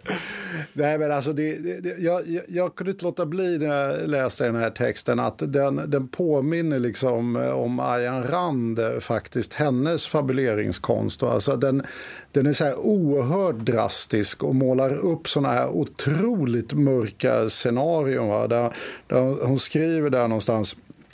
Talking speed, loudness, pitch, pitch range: 150 wpm, -24 LUFS, 140 Hz, 120-160 Hz